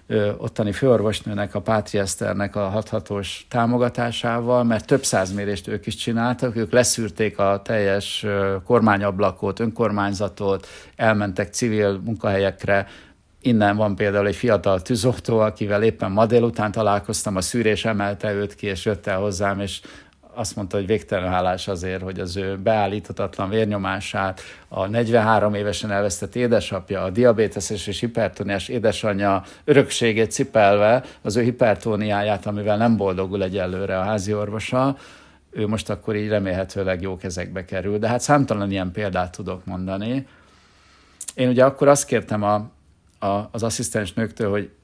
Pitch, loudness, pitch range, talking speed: 105 Hz, -21 LUFS, 100-115 Hz, 140 wpm